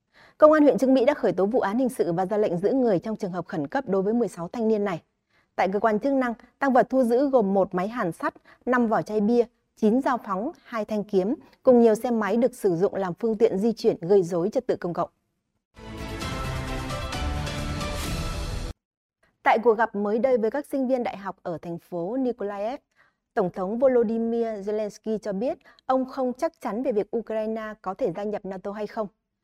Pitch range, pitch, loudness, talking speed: 190-250 Hz, 220 Hz, -25 LUFS, 215 wpm